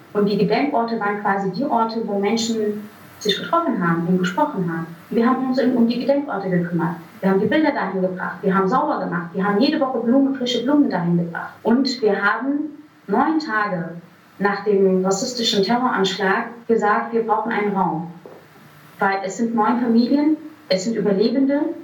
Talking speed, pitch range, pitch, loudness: 175 wpm, 195-250 Hz, 210 Hz, -20 LUFS